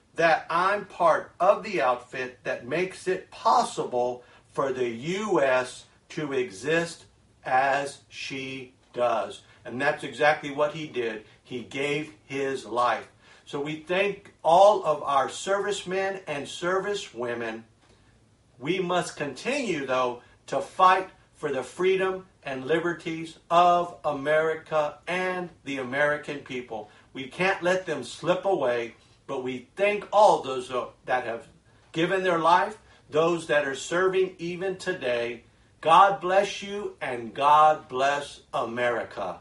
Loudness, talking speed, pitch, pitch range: -26 LUFS, 125 wpm, 145 Hz, 125-175 Hz